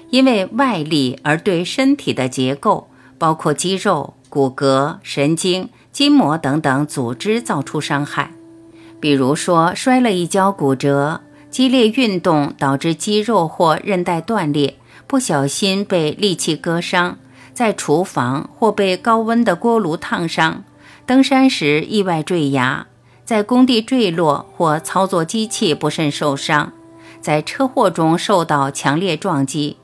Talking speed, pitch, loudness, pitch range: 205 characters per minute, 165 Hz, -16 LUFS, 145-210 Hz